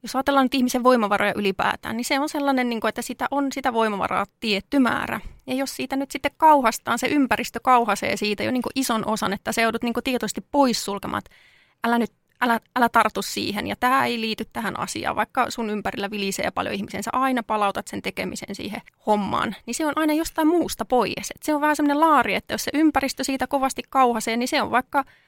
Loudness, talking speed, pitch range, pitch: -23 LUFS, 200 wpm, 220-275 Hz, 245 Hz